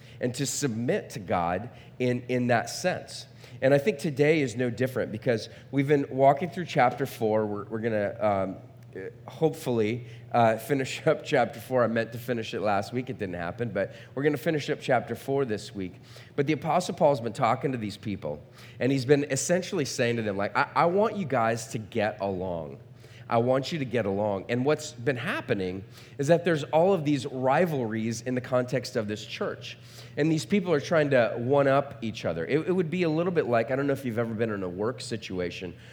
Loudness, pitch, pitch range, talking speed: -27 LUFS, 125 Hz, 115-145 Hz, 220 wpm